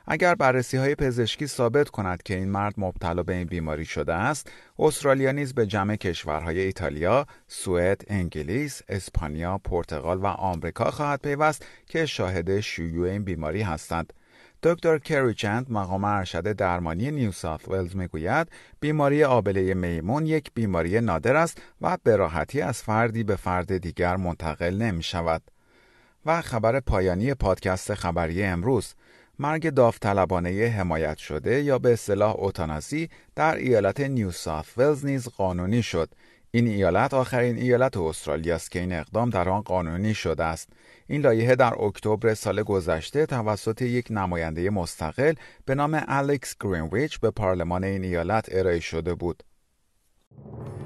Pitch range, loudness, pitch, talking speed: 90-125 Hz, -25 LUFS, 100 Hz, 140 wpm